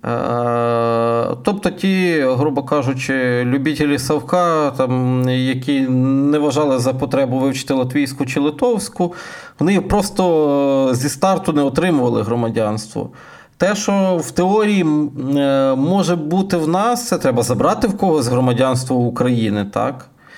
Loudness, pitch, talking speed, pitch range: -17 LUFS, 145 Hz, 110 wpm, 130-175 Hz